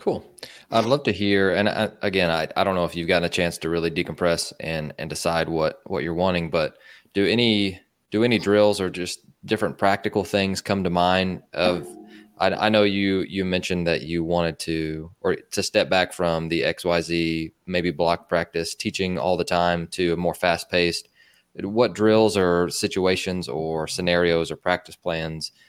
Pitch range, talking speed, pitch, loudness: 85-100 Hz, 185 wpm, 90 Hz, -23 LUFS